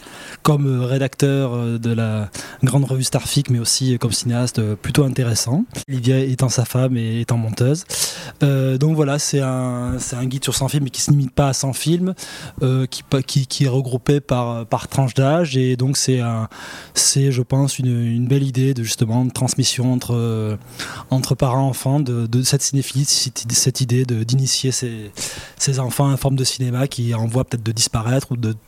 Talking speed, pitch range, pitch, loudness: 185 wpm, 120-135 Hz, 130 Hz, -19 LUFS